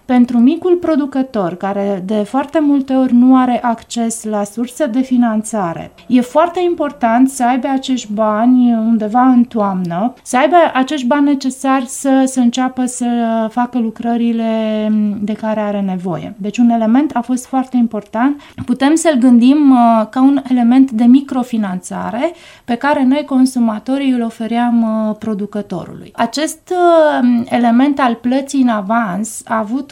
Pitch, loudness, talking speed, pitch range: 245 Hz, -14 LUFS, 140 wpm, 225-265 Hz